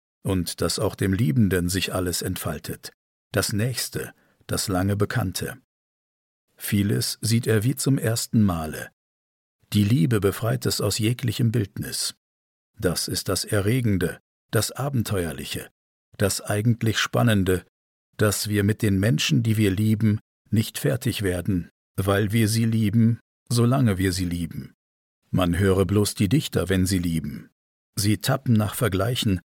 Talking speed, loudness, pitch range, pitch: 135 wpm, -24 LUFS, 90-115 Hz, 105 Hz